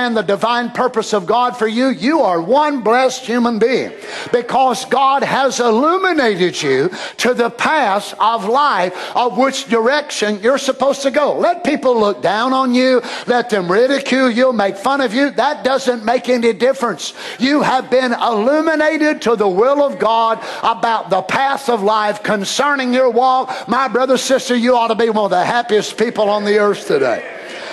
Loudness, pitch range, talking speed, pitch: -15 LUFS, 225-270 Hz, 175 wpm, 245 Hz